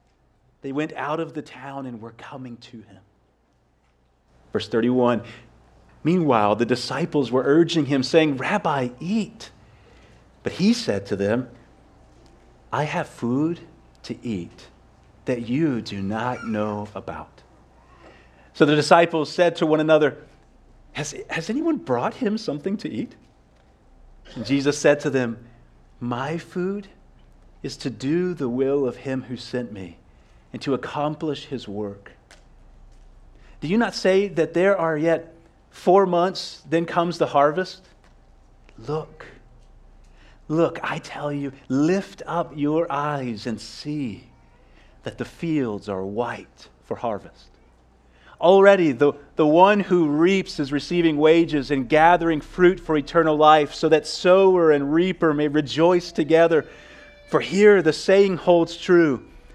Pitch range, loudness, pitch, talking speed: 115-170 Hz, -21 LUFS, 145 Hz, 135 wpm